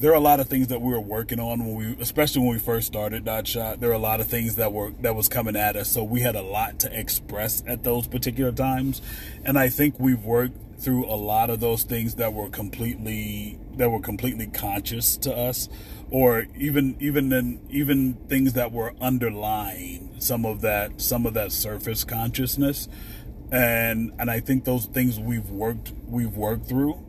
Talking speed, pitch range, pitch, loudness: 205 wpm, 110-125 Hz, 115 Hz, -24 LUFS